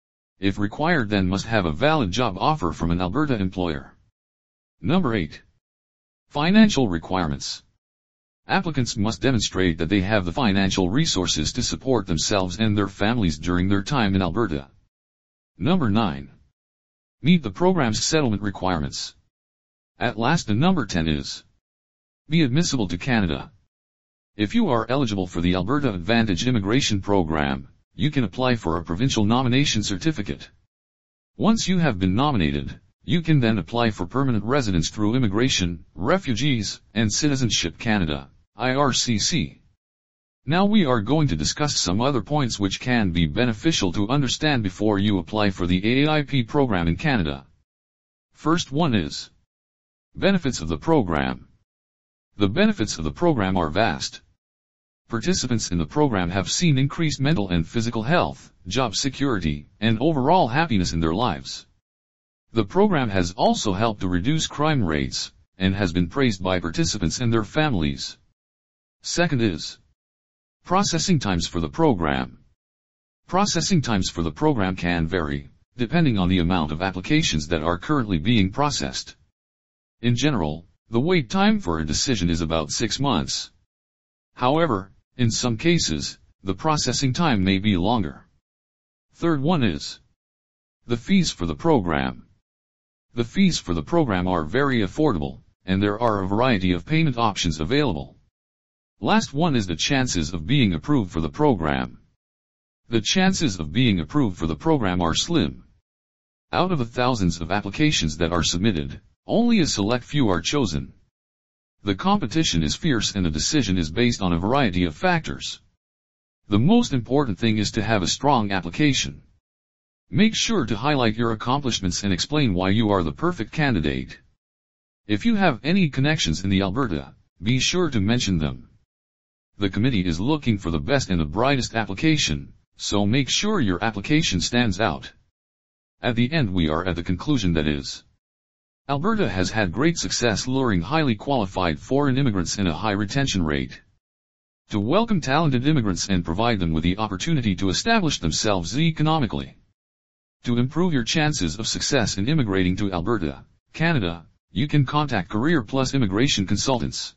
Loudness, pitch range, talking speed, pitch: -22 LUFS, 80-130 Hz, 155 wpm, 100 Hz